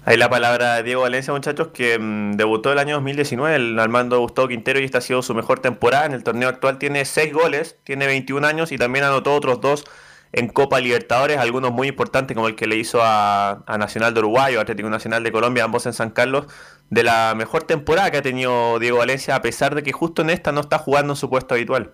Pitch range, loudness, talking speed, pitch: 115-140 Hz, -19 LUFS, 240 wpm, 130 Hz